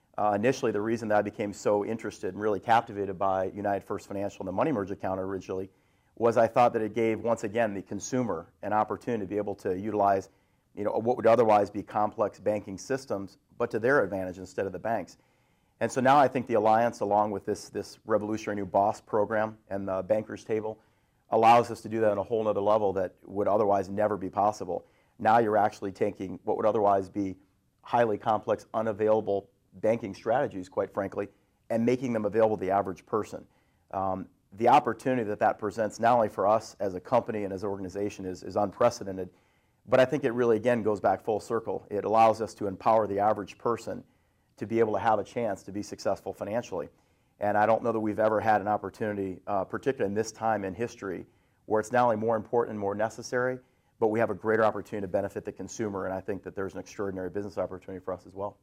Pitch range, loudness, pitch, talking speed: 100-110 Hz, -28 LUFS, 105 Hz, 215 wpm